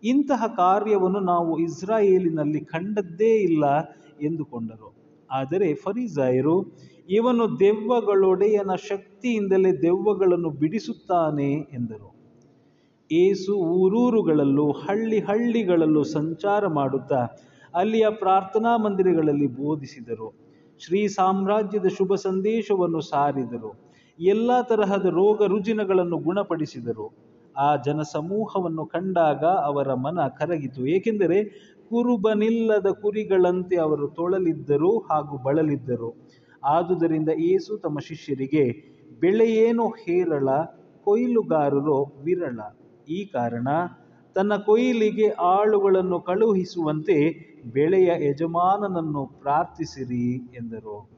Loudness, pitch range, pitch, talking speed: -23 LUFS, 145-205 Hz, 175 Hz, 80 wpm